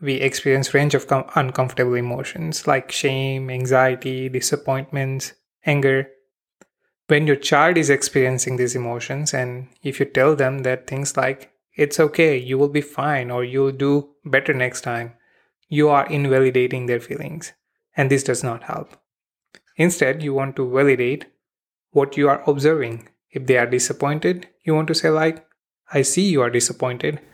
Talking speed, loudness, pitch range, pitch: 160 wpm, -20 LUFS, 130-150 Hz, 135 Hz